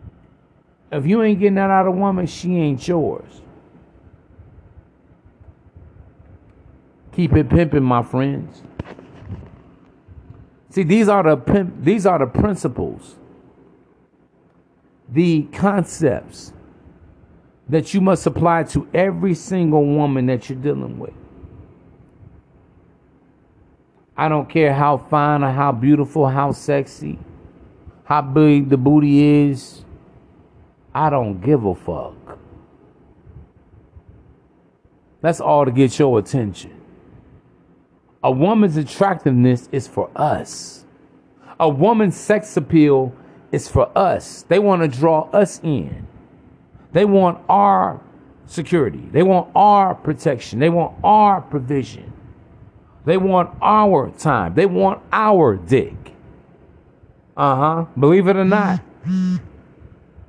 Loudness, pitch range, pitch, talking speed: -17 LUFS, 130-180 Hz, 150 Hz, 110 wpm